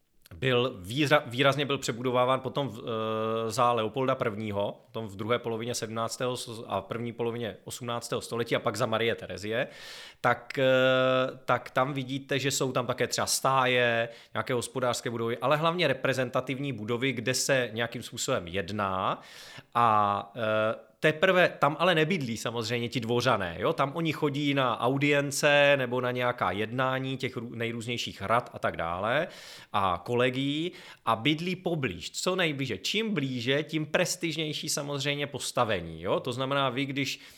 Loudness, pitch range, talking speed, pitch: -28 LUFS, 115-140 Hz, 150 wpm, 125 Hz